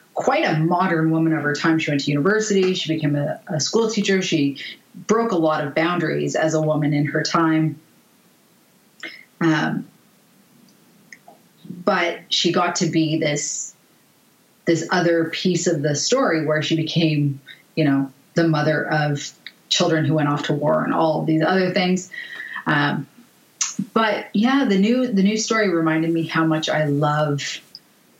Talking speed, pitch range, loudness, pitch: 160 wpm, 155-195 Hz, -20 LUFS, 165 Hz